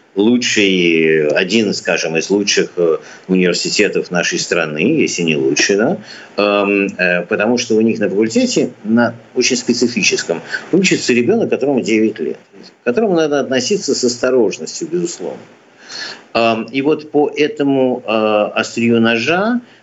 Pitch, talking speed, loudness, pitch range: 120 Hz, 120 wpm, -15 LUFS, 105-145 Hz